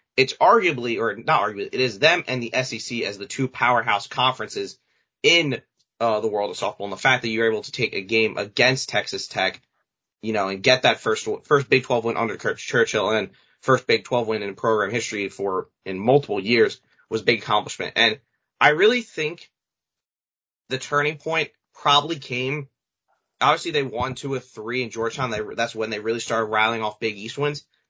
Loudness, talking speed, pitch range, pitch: -22 LUFS, 195 wpm, 110-145 Hz, 125 Hz